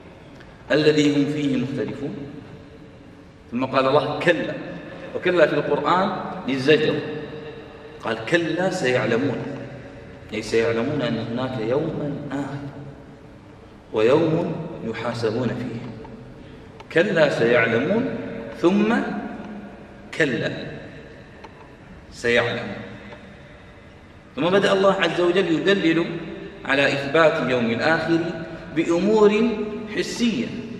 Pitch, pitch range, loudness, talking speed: 150 Hz, 130-175 Hz, -21 LUFS, 80 wpm